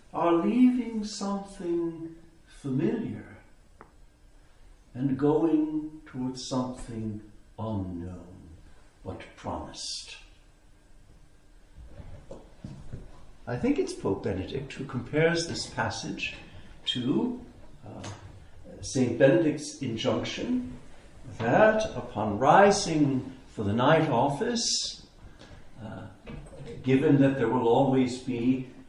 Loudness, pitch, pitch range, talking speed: -27 LUFS, 130 Hz, 110-165 Hz, 80 wpm